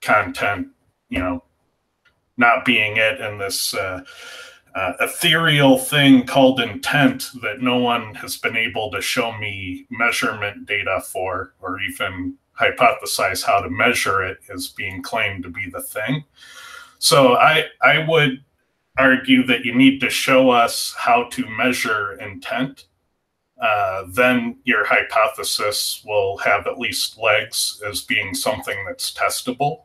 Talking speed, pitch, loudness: 140 wpm, 135 Hz, -18 LUFS